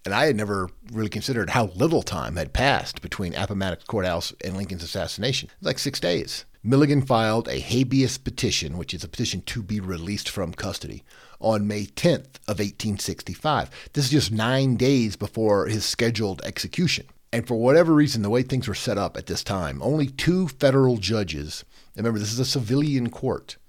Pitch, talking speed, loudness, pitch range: 110 Hz, 185 wpm, -24 LUFS, 100-130 Hz